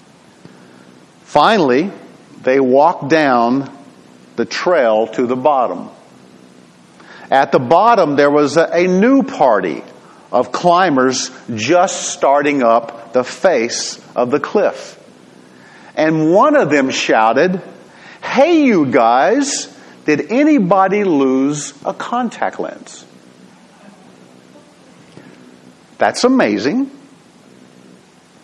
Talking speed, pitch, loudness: 90 wpm, 130 Hz, -14 LUFS